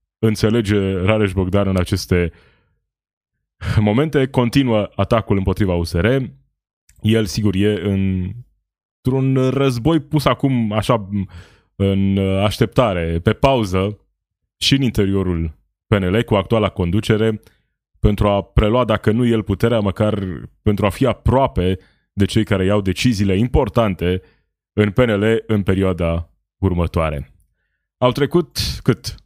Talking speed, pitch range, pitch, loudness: 115 wpm, 95-115 Hz, 105 Hz, -18 LUFS